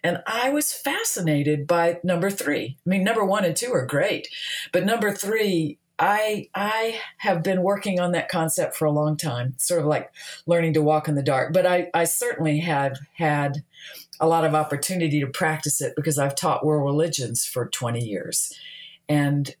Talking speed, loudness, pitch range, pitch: 185 wpm, -23 LUFS, 150-190 Hz, 160 Hz